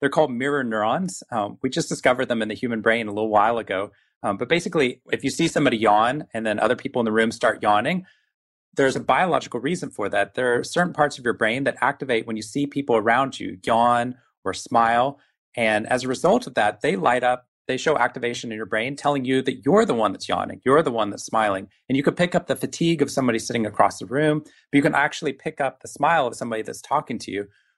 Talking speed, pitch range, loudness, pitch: 245 wpm, 115-140 Hz, -22 LUFS, 125 Hz